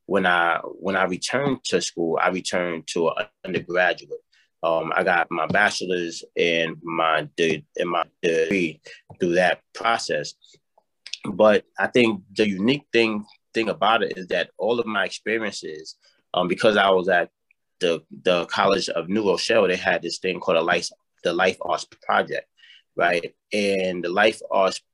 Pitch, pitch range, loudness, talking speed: 100 Hz, 85-135 Hz, -22 LUFS, 165 wpm